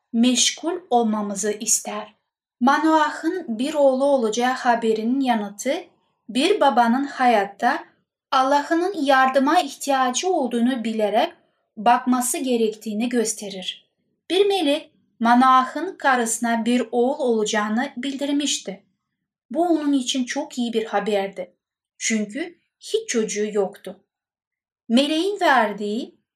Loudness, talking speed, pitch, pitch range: -21 LUFS, 95 wpm, 250 Hz, 220-290 Hz